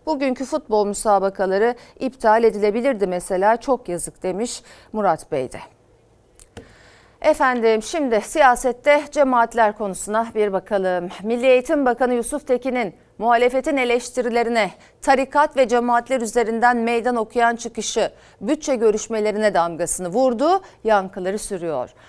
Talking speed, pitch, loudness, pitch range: 105 wpm, 230 Hz, -20 LUFS, 200-255 Hz